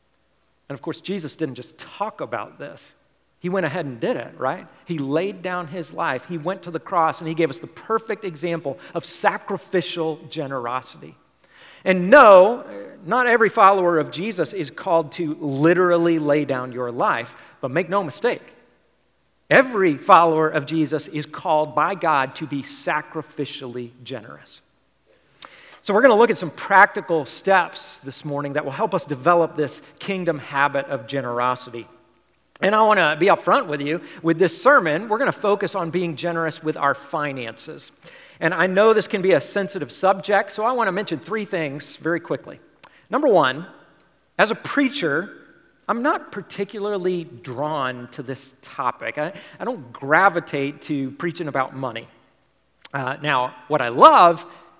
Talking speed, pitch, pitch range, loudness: 165 wpm, 165 Hz, 140-190 Hz, -20 LUFS